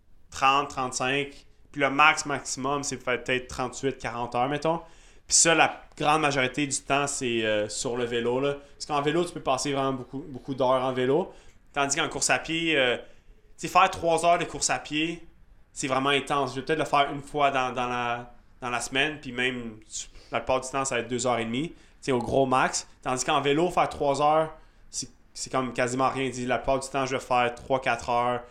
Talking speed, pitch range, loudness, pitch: 225 wpm, 125-145 Hz, -26 LUFS, 135 Hz